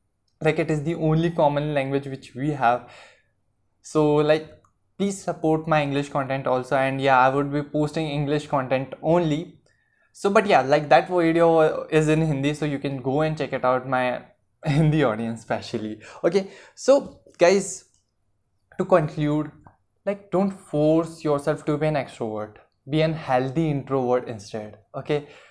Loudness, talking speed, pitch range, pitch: -23 LUFS, 160 wpm, 130-155 Hz, 150 Hz